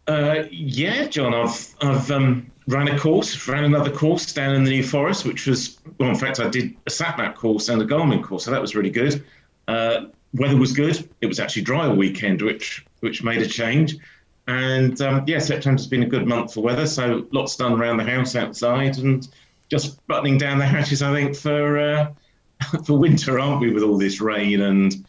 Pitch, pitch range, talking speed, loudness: 135 Hz, 120-145 Hz, 210 wpm, -21 LUFS